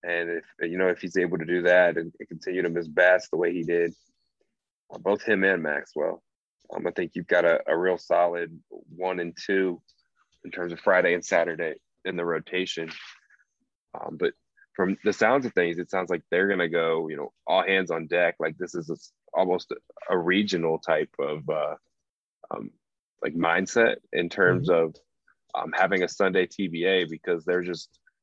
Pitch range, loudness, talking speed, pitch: 85-90 Hz, -26 LUFS, 185 wpm, 85 Hz